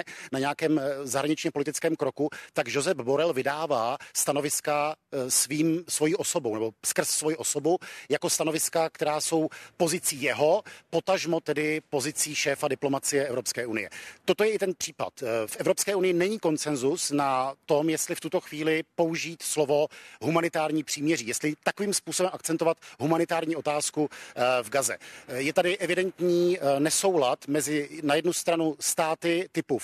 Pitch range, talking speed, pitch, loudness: 145-170 Hz, 135 wpm, 155 Hz, -27 LUFS